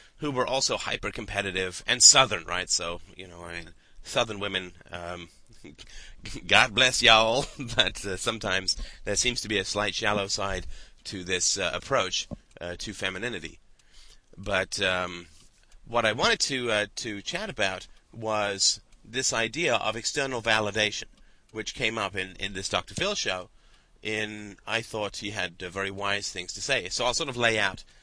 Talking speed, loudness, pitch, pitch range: 170 wpm, -26 LUFS, 105 Hz, 95-115 Hz